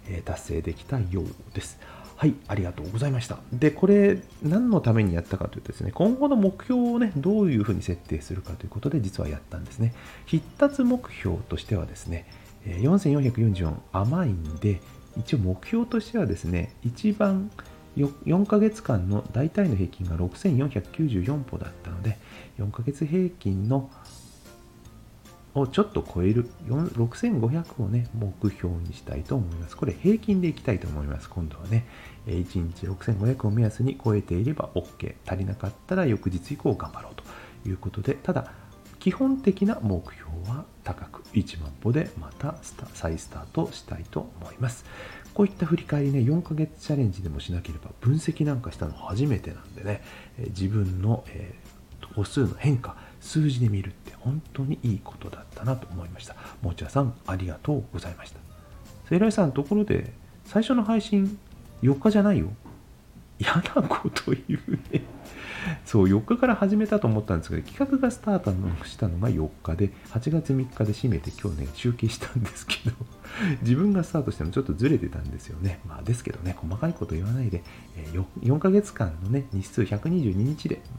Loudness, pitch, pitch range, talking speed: -27 LUFS, 110 Hz, 95-145 Hz, 335 characters per minute